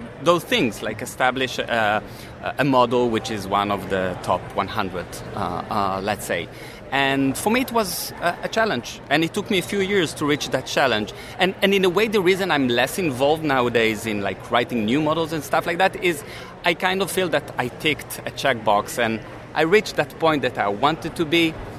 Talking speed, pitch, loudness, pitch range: 210 wpm, 145 Hz, -22 LUFS, 120-175 Hz